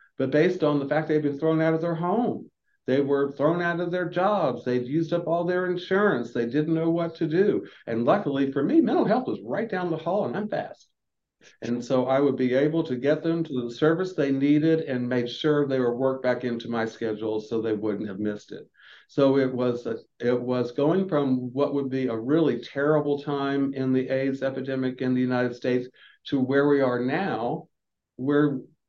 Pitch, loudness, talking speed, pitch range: 140 Hz, -25 LUFS, 215 wpm, 125-160 Hz